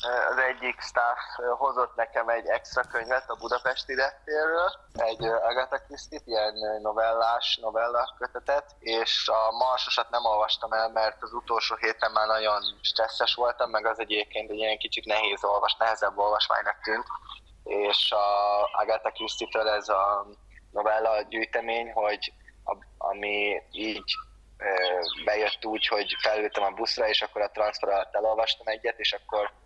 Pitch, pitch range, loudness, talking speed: 110 Hz, 105-120 Hz, -27 LUFS, 140 wpm